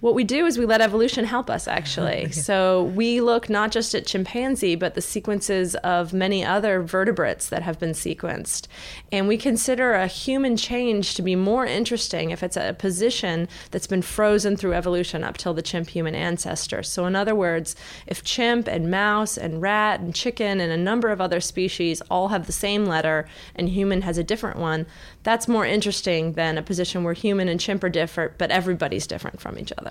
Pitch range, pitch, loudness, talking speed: 175-215 Hz, 190 Hz, -23 LUFS, 200 wpm